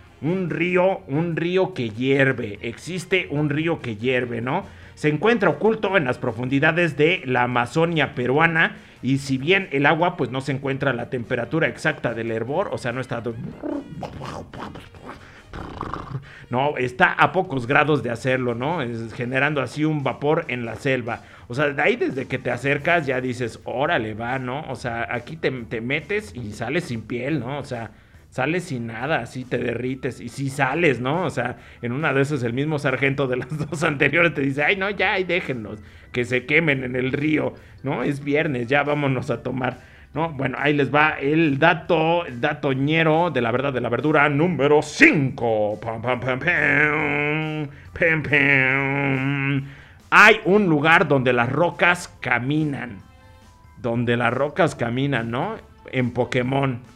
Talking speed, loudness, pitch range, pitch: 175 wpm, -21 LUFS, 120-155 Hz, 135 Hz